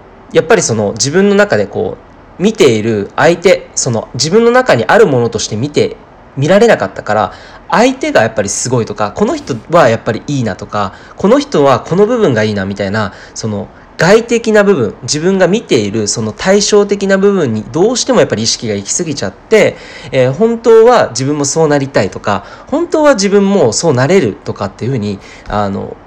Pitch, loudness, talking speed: 145 Hz, -11 LUFS, 380 characters per minute